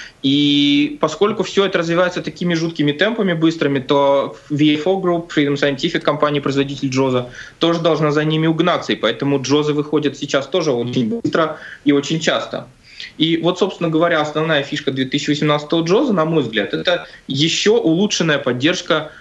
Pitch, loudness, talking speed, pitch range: 155 Hz, -17 LUFS, 150 wpm, 145-170 Hz